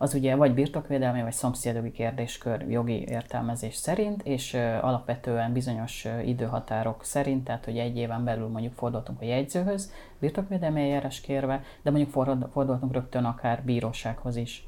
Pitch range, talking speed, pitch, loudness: 115-135 Hz, 140 wpm, 125 Hz, -29 LUFS